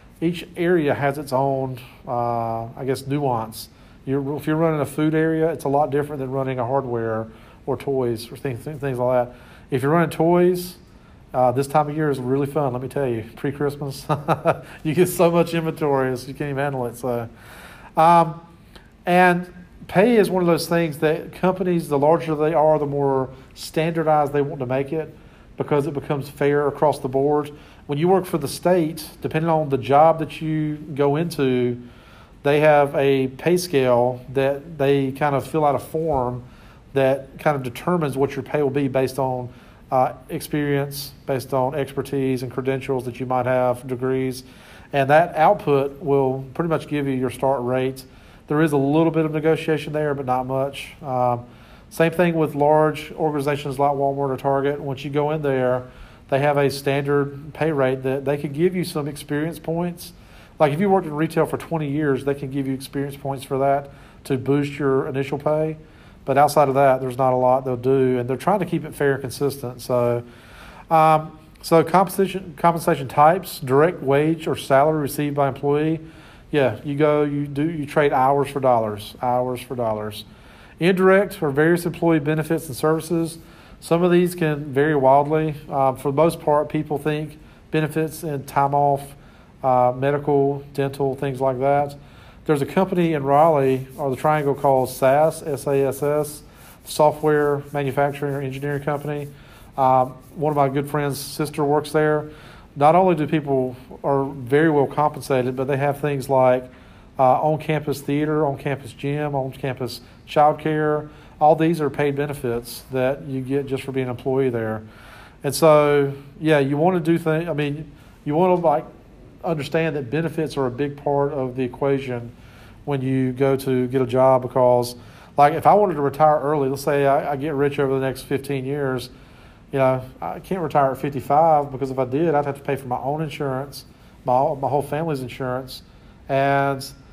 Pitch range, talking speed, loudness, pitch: 130-155 Hz, 185 wpm, -21 LUFS, 140 Hz